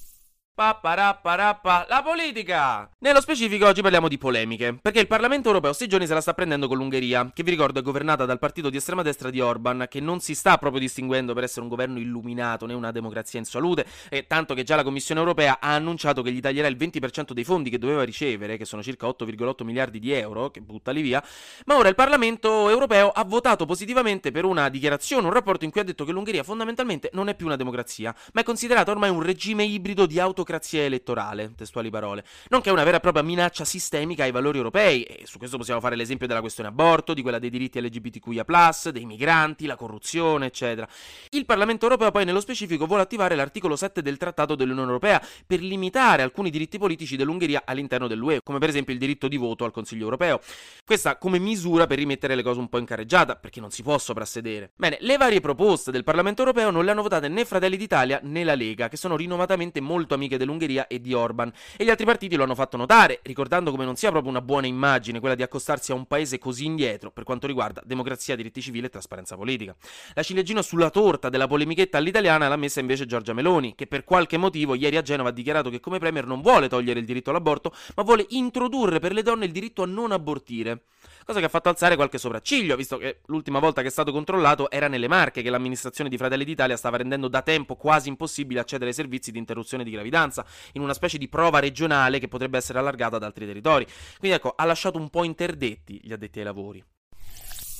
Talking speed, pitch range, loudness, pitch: 220 wpm, 125-180 Hz, -23 LUFS, 145 Hz